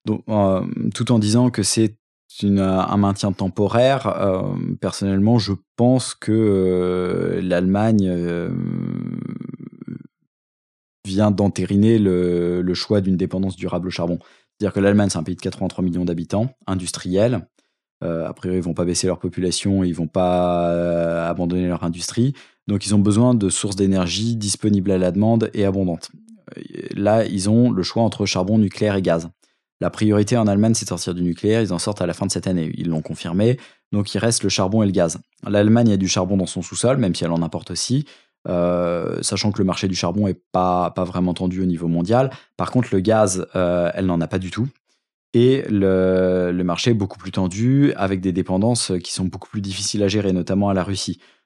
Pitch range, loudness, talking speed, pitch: 90-105 Hz, -20 LUFS, 200 wpm, 95 Hz